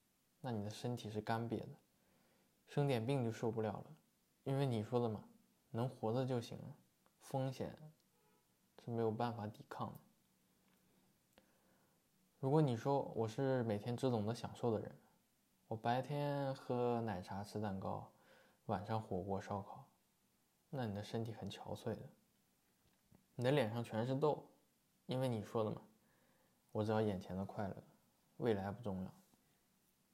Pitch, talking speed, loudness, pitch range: 115 Hz, 205 characters per minute, -42 LUFS, 105-130 Hz